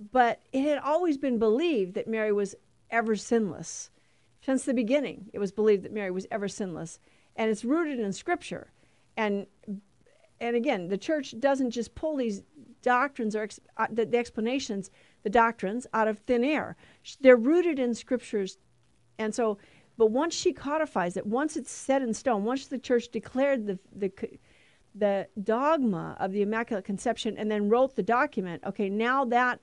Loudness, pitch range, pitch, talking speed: -28 LUFS, 210-260 Hz, 230 Hz, 170 wpm